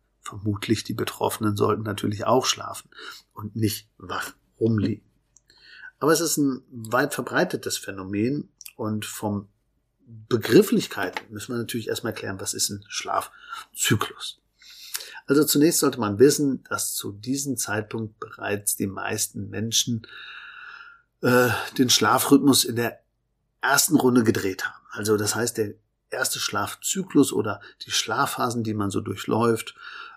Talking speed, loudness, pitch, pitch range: 130 wpm, -24 LUFS, 115 Hz, 105-140 Hz